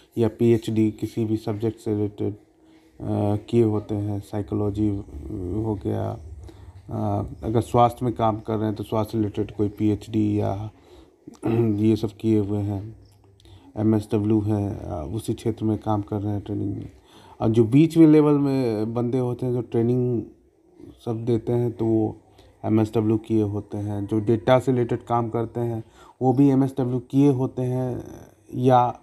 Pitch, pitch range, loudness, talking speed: 110 Hz, 105-120 Hz, -23 LUFS, 170 wpm